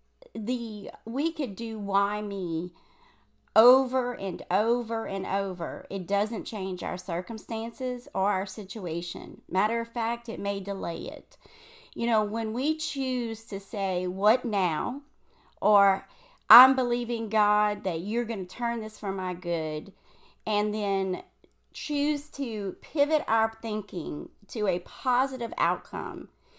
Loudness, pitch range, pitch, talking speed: -28 LUFS, 195-245 Hz, 220 Hz, 135 wpm